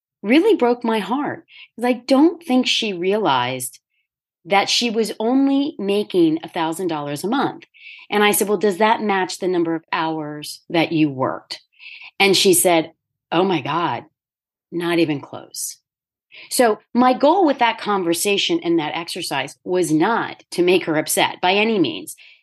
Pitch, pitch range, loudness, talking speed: 200 Hz, 165-250 Hz, -19 LUFS, 160 wpm